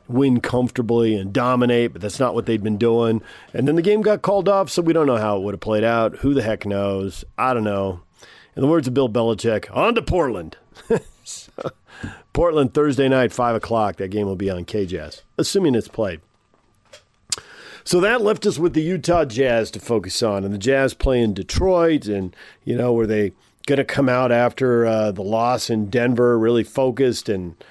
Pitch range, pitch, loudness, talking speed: 105-135 Hz, 115 Hz, -20 LUFS, 200 wpm